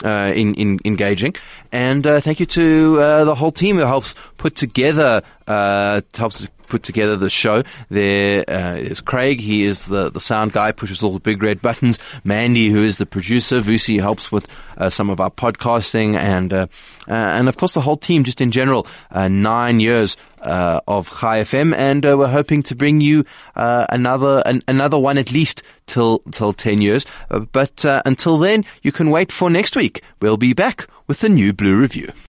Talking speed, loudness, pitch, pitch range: 205 wpm, -16 LUFS, 120 Hz, 105-140 Hz